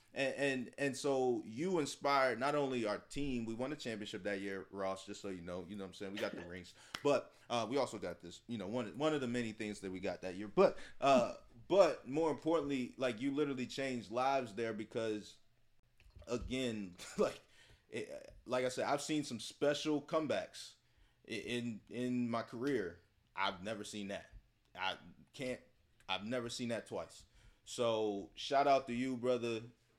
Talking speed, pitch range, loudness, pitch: 190 wpm, 105-130 Hz, -38 LUFS, 120 Hz